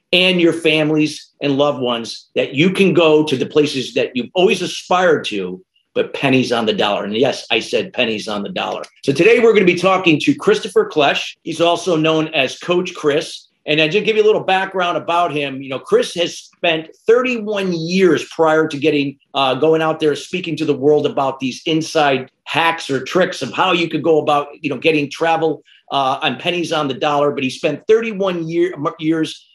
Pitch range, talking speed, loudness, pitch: 145-175 Hz, 210 wpm, -16 LUFS, 160 Hz